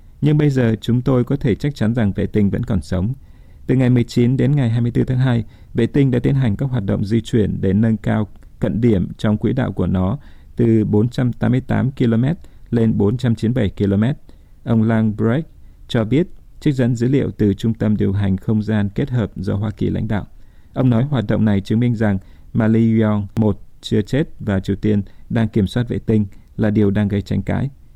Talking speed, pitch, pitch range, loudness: 210 wpm, 110 Hz, 105-120 Hz, -18 LUFS